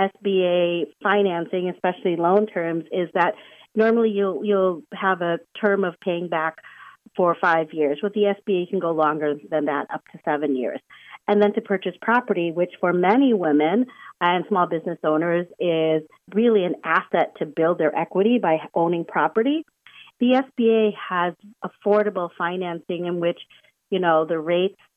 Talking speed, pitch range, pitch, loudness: 165 wpm, 170-205 Hz, 180 Hz, -22 LUFS